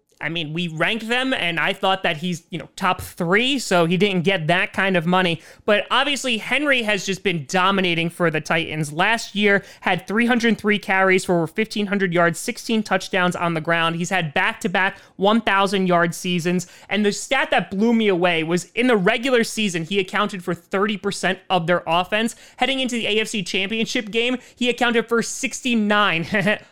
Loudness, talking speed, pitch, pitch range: -20 LUFS, 175 wpm, 195 Hz, 180-225 Hz